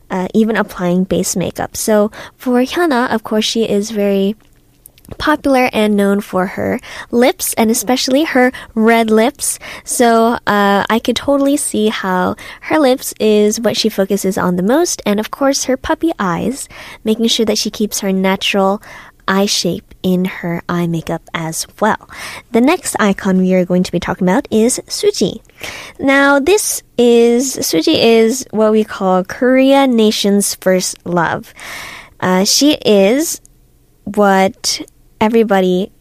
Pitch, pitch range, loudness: 215 Hz, 190-250 Hz, -14 LUFS